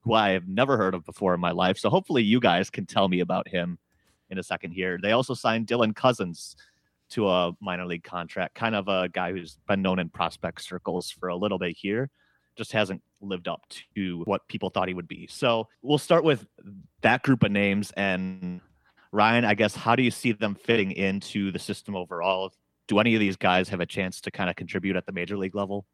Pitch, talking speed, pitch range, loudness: 95 Hz, 225 wpm, 90-110 Hz, -26 LUFS